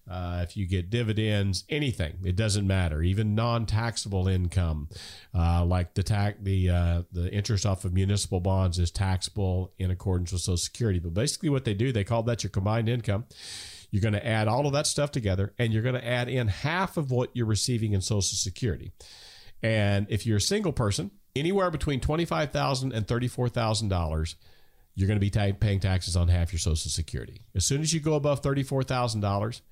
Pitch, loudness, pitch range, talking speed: 105 Hz, -28 LUFS, 95-120 Hz, 190 wpm